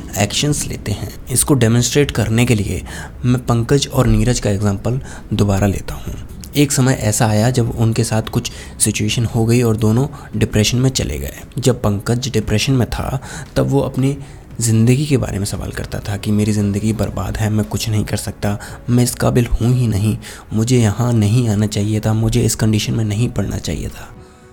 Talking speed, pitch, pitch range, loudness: 190 wpm, 110 Hz, 105-125 Hz, -17 LUFS